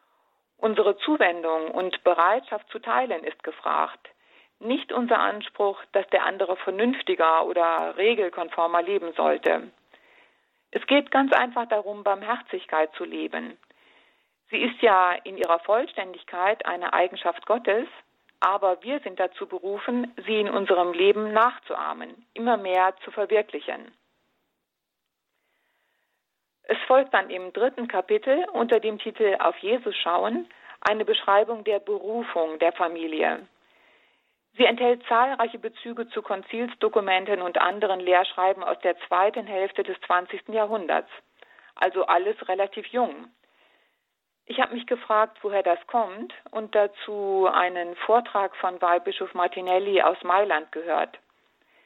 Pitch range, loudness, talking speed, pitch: 185-235 Hz, -24 LUFS, 120 wpm, 205 Hz